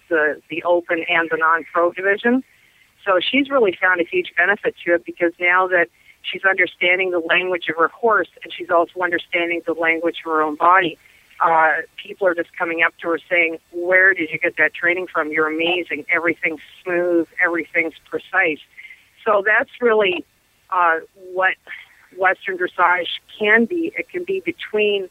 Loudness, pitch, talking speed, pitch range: -18 LUFS, 175 Hz, 170 wpm, 165-190 Hz